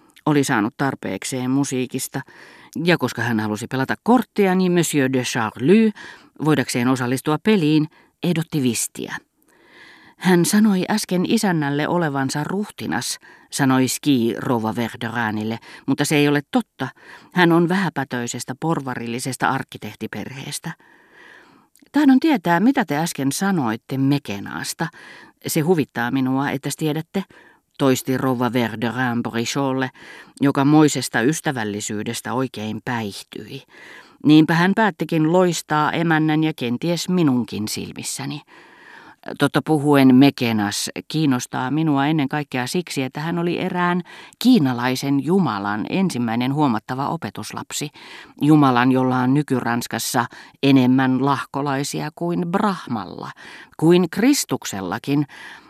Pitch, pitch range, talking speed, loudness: 140 Hz, 125-170 Hz, 100 wpm, -20 LUFS